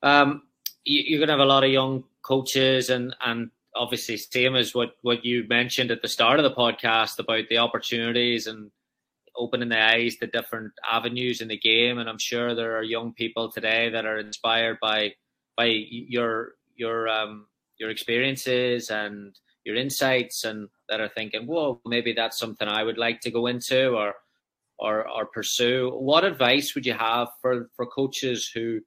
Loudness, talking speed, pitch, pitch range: -24 LUFS, 180 wpm, 115 Hz, 110-125 Hz